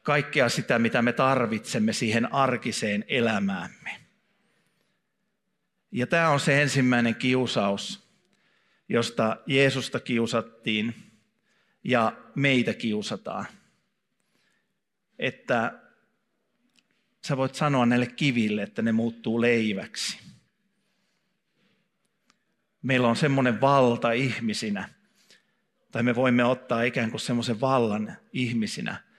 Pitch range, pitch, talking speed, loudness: 115-195 Hz, 130 Hz, 90 wpm, -25 LUFS